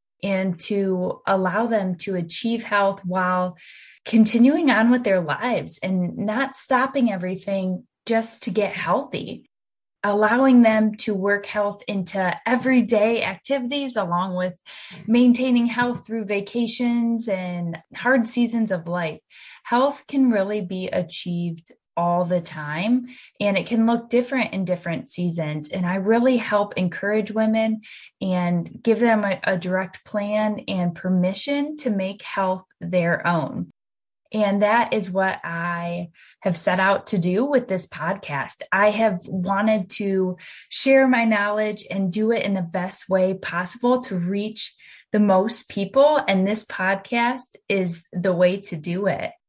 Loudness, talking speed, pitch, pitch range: -22 LUFS, 145 wpm, 200 Hz, 185-230 Hz